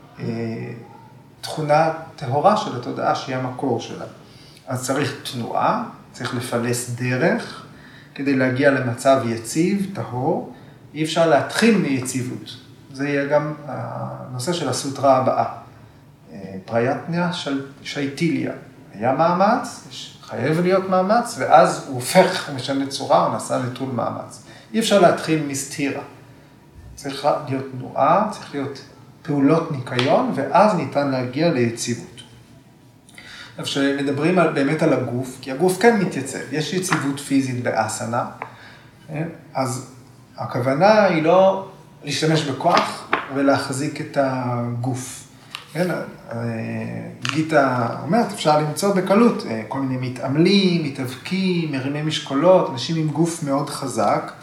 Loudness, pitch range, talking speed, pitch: -20 LUFS, 130-160 Hz, 110 wpm, 140 Hz